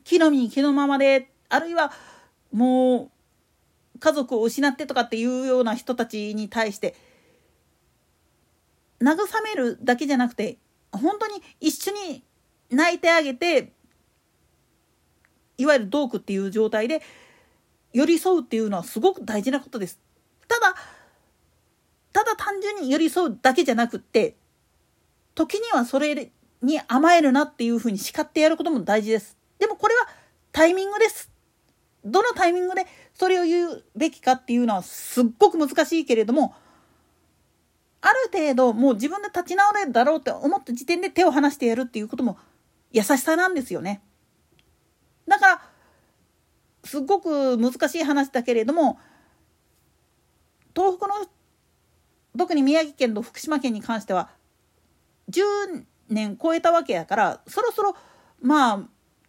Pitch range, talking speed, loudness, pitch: 245-350 Hz, 290 characters per minute, -22 LUFS, 285 Hz